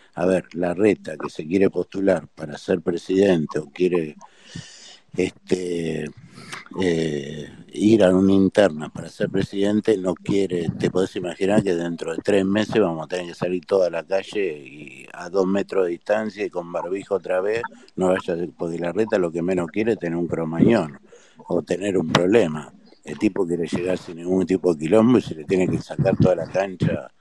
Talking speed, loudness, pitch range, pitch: 190 wpm, -22 LUFS, 85-100 Hz, 90 Hz